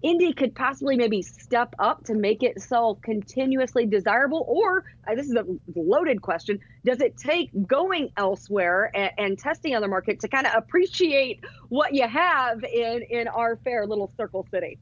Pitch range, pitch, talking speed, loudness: 210-270 Hz, 235 Hz, 175 wpm, -24 LUFS